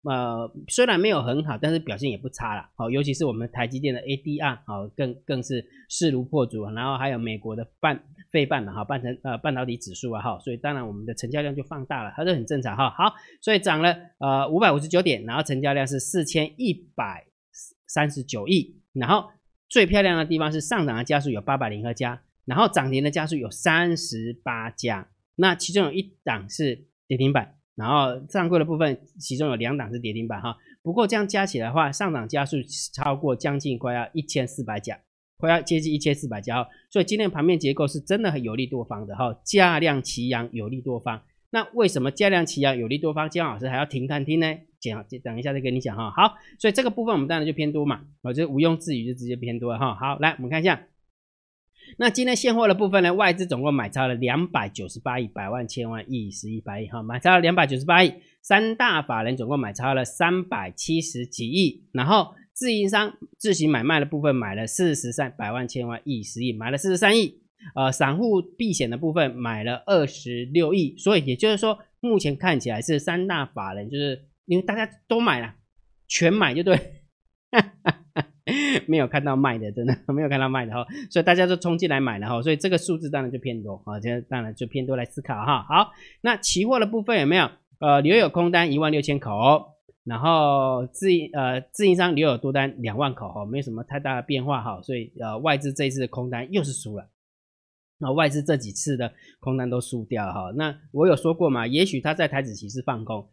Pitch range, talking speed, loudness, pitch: 125-170 Hz, 325 characters per minute, -24 LUFS, 140 Hz